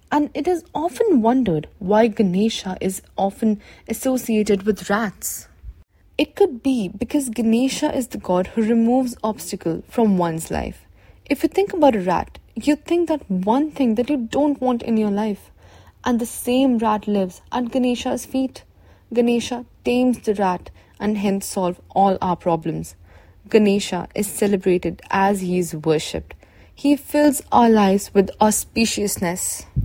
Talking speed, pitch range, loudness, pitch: 150 wpm, 190-255 Hz, -20 LUFS, 220 Hz